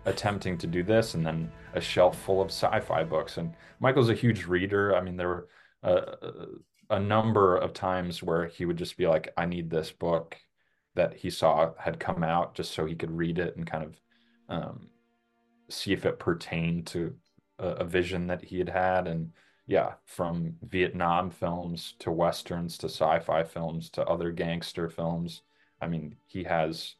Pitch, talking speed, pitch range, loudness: 85 Hz, 180 wpm, 85-95 Hz, -29 LUFS